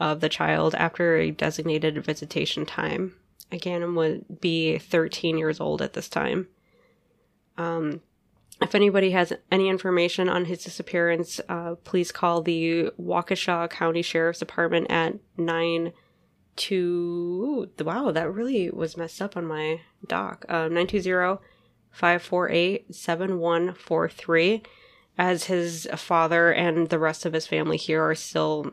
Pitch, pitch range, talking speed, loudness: 170 Hz, 160-180 Hz, 125 wpm, -25 LUFS